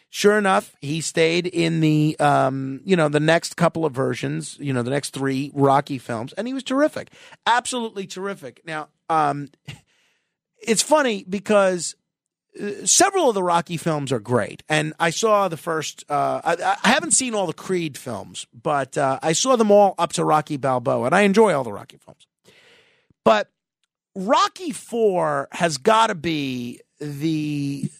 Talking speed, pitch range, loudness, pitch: 165 wpm, 145-205 Hz, -21 LUFS, 165 Hz